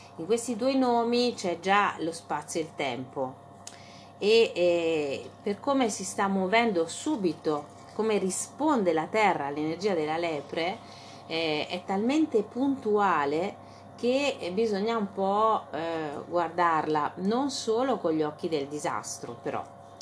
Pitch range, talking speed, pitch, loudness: 160-230 Hz, 130 wpm, 185 Hz, -28 LUFS